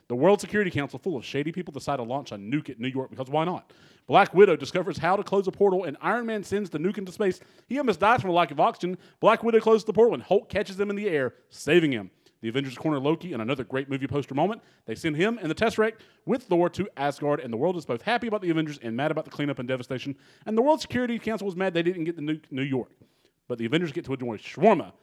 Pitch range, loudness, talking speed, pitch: 140-200 Hz, -26 LUFS, 275 wpm, 170 Hz